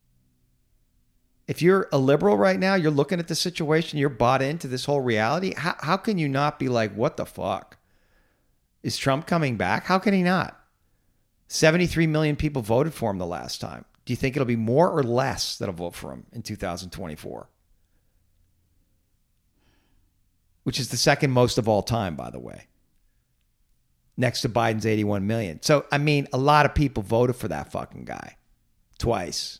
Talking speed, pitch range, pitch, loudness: 175 wpm, 100-150 Hz, 125 Hz, -24 LUFS